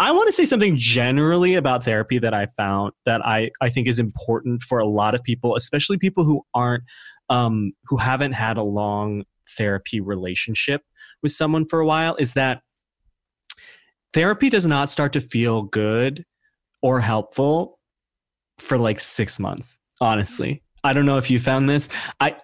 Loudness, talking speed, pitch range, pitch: -20 LUFS, 170 wpm, 110-145 Hz, 125 Hz